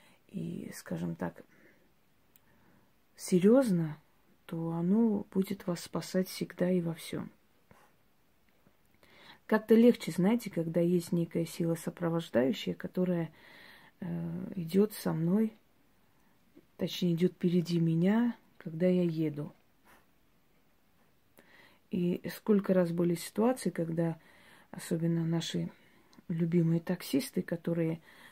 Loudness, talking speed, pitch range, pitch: -32 LUFS, 95 wpm, 165-195 Hz, 175 Hz